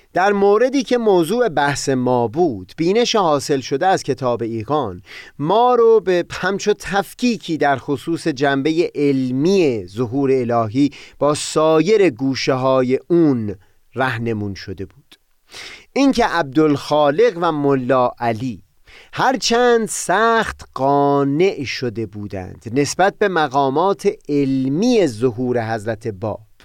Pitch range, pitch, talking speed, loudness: 125-185 Hz, 145 Hz, 115 wpm, -17 LUFS